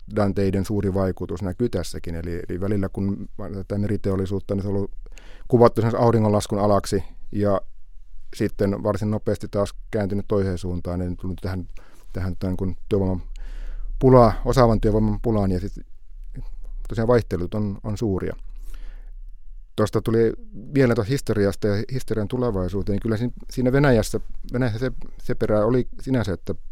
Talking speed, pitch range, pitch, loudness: 140 wpm, 95-115 Hz, 100 Hz, -23 LUFS